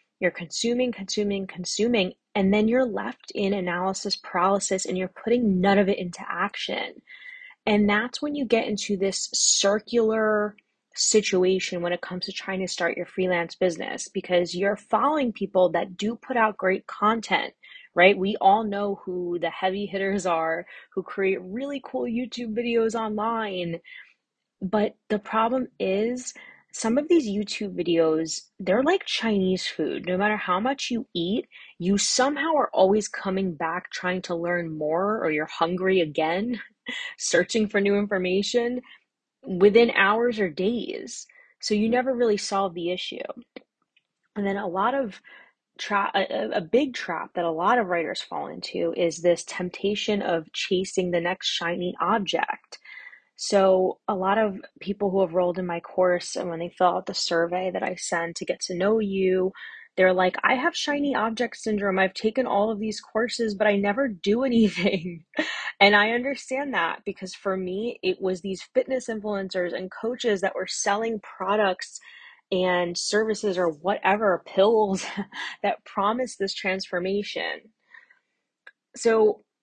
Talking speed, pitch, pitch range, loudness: 160 wpm, 200 Hz, 185-230 Hz, -25 LUFS